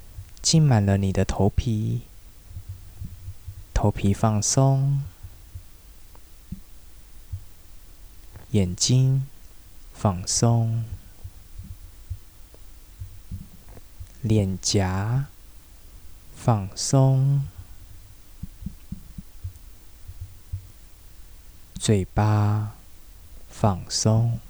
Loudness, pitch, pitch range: -23 LUFS, 95 Hz, 85-105 Hz